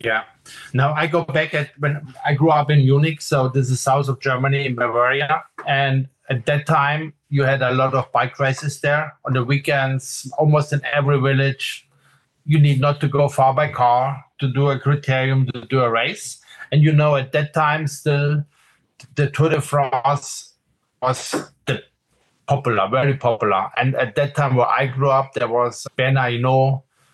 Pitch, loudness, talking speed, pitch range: 140 Hz, -19 LUFS, 185 wpm, 130-145 Hz